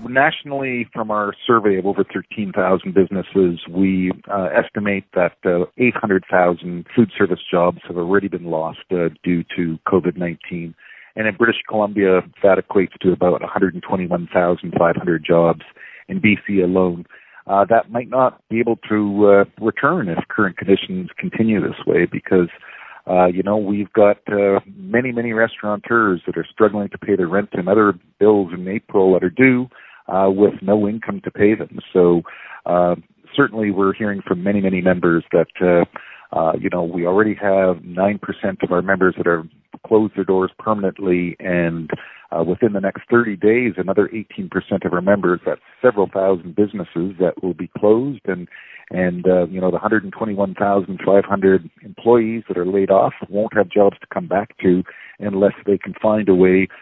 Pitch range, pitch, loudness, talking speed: 90-105 Hz, 95 Hz, -18 LUFS, 165 wpm